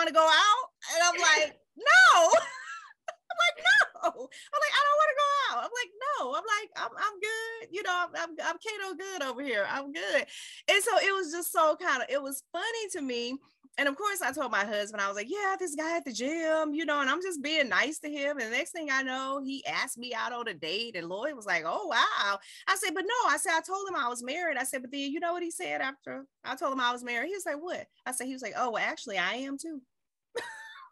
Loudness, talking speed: -28 LUFS, 265 wpm